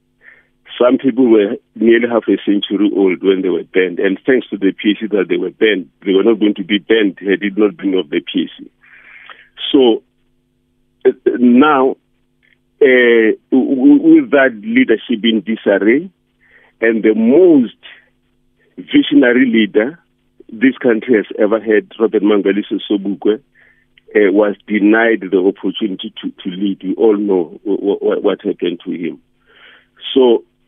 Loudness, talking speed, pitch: -13 LUFS, 150 wpm, 115 Hz